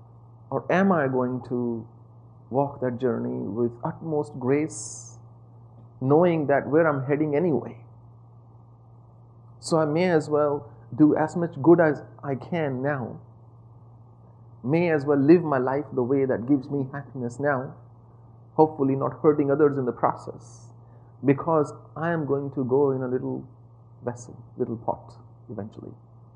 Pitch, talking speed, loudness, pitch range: 125 Hz, 145 wpm, -24 LUFS, 115-145 Hz